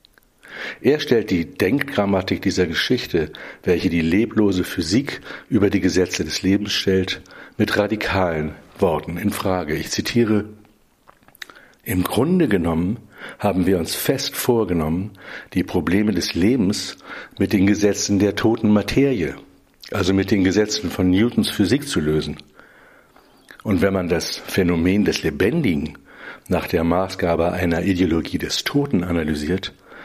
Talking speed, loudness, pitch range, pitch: 130 wpm, -20 LUFS, 85-105 Hz, 95 Hz